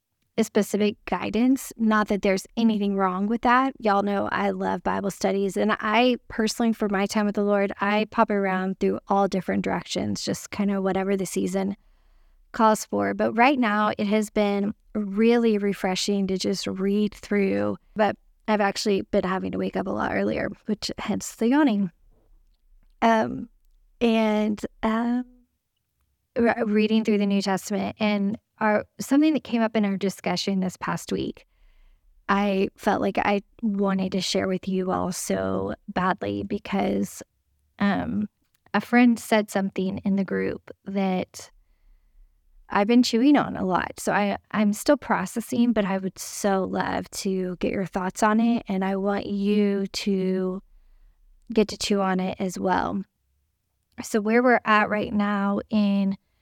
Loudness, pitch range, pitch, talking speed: -24 LUFS, 190-220 Hz, 200 Hz, 160 wpm